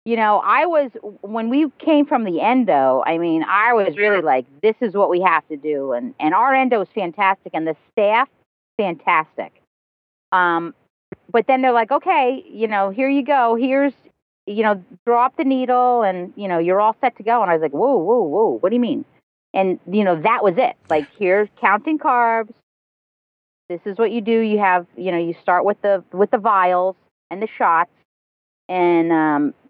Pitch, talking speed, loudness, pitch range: 210 Hz, 200 wpm, -18 LUFS, 180-250 Hz